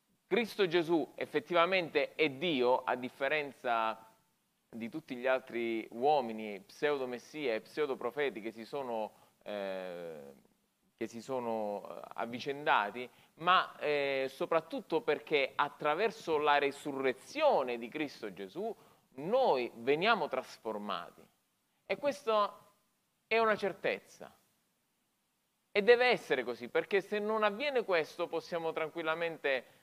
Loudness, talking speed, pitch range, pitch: -34 LUFS, 105 wpm, 120-190 Hz, 150 Hz